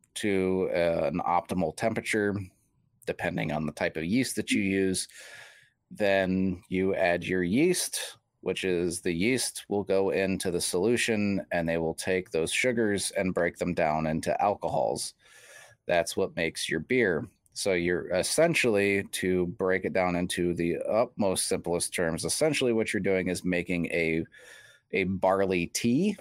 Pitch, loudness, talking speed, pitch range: 95 Hz, -28 LUFS, 155 wpm, 90-100 Hz